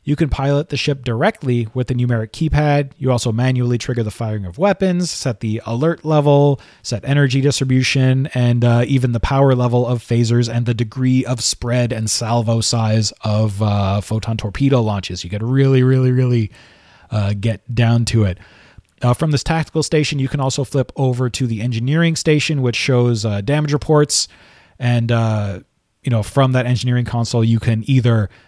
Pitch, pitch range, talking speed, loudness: 125 Hz, 115-140 Hz, 180 wpm, -17 LUFS